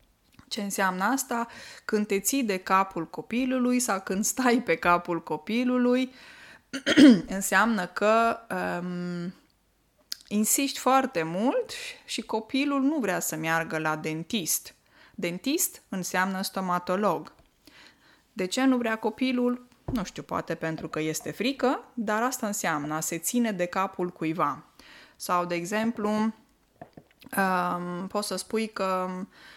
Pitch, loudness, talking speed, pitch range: 205 Hz, -27 LUFS, 125 wpm, 175-245 Hz